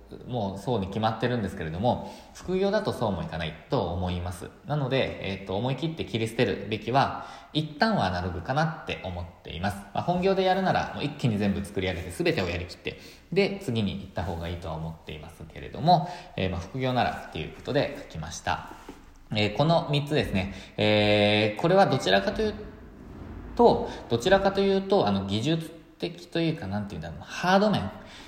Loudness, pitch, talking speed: -27 LUFS, 115 Hz, 405 characters per minute